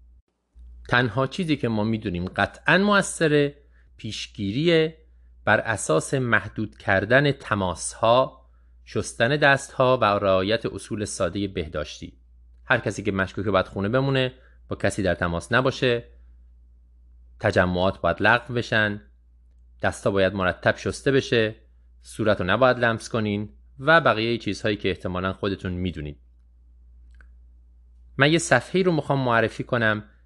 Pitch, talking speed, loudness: 100 Hz, 125 wpm, -23 LUFS